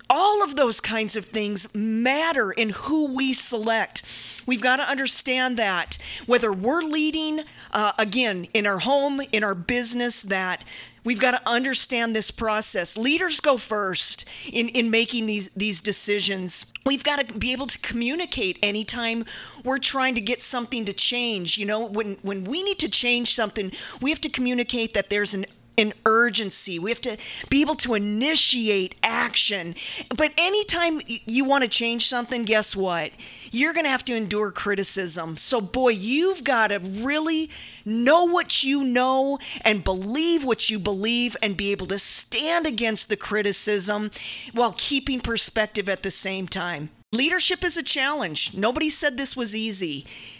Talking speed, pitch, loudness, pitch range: 165 wpm, 235 Hz, -20 LUFS, 210-270 Hz